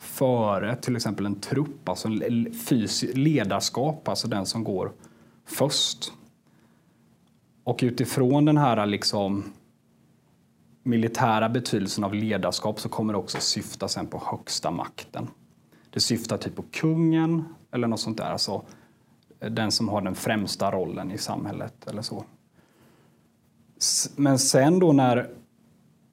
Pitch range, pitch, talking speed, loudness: 105-135 Hz, 115 Hz, 125 wpm, -25 LUFS